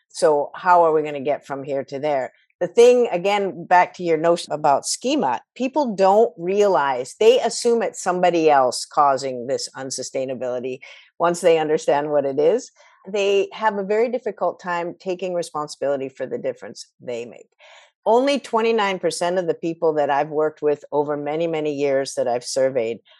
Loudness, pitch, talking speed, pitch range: -20 LUFS, 170 Hz, 170 wpm, 145-205 Hz